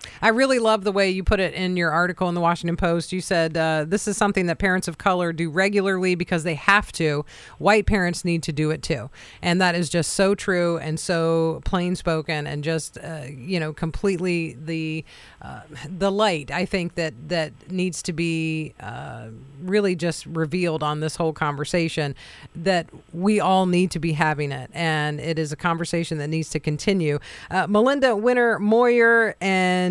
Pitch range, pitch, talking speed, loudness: 155-185 Hz, 170 Hz, 190 wpm, -22 LUFS